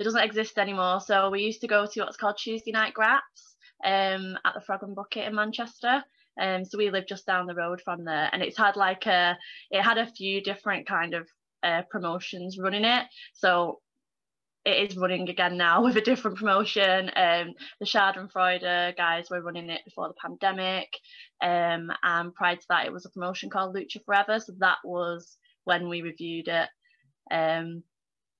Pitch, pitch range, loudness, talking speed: 195 Hz, 175-215 Hz, -27 LUFS, 190 wpm